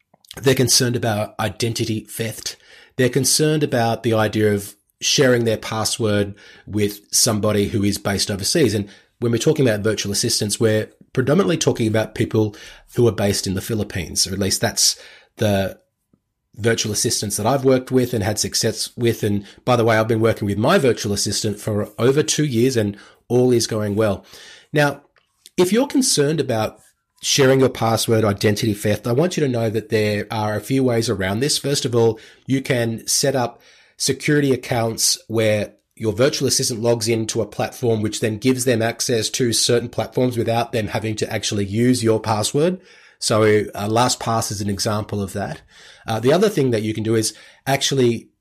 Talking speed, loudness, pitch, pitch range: 185 wpm, -19 LUFS, 115 Hz, 105-125 Hz